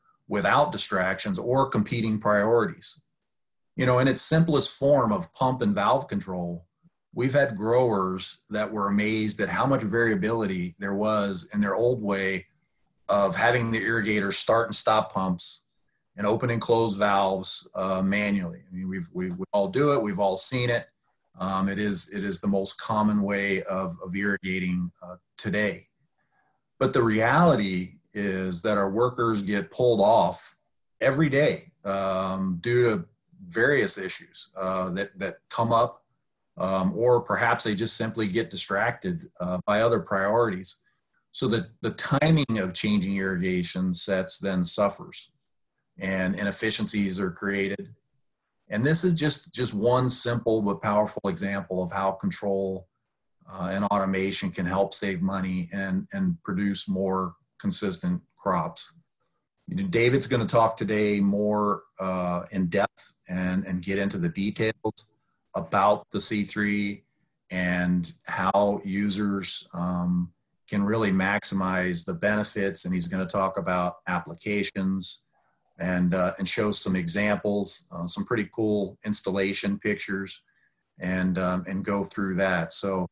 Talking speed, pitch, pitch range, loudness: 145 wpm, 100 Hz, 95-115 Hz, -26 LUFS